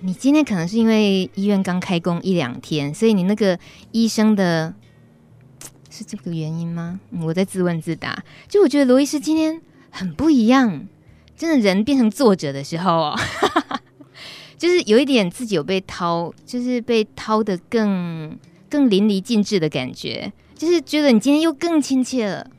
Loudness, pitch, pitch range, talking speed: -19 LUFS, 205 Hz, 175-255 Hz, 255 characters per minute